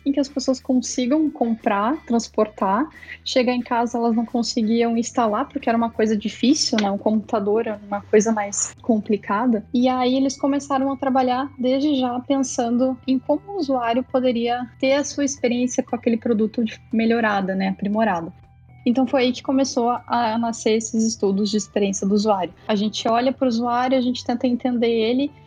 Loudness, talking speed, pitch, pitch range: -21 LUFS, 175 wpm, 240 Hz, 225-260 Hz